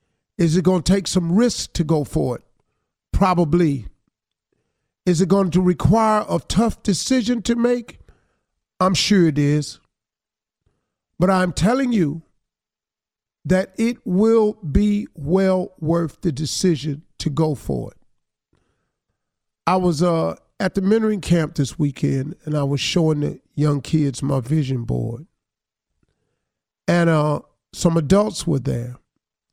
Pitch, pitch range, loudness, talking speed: 170 Hz, 150-190 Hz, -20 LUFS, 135 wpm